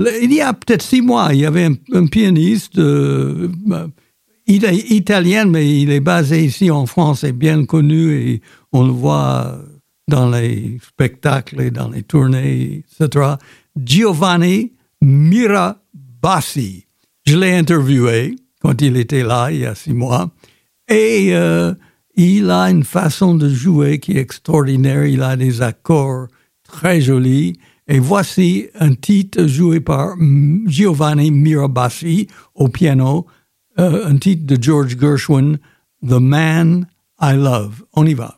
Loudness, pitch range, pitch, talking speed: -14 LUFS, 135-180 Hz, 150 Hz, 140 wpm